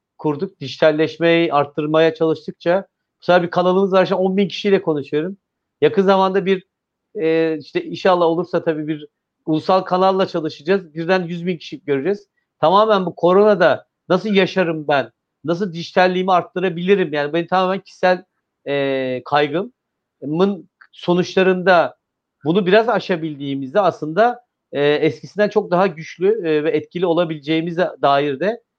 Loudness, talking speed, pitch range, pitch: -18 LUFS, 125 wpm, 155-190 Hz, 175 Hz